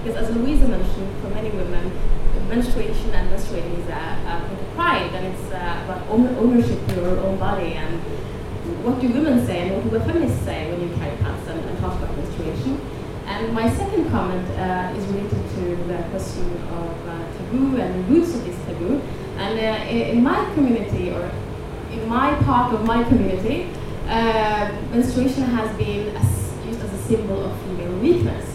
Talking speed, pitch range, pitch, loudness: 180 wpm, 225-260 Hz, 245 Hz, -22 LUFS